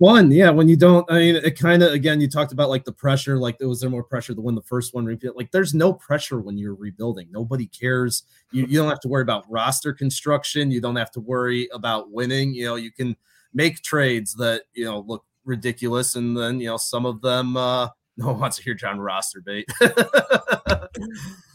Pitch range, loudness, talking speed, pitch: 120-145 Hz, -21 LUFS, 220 wpm, 125 Hz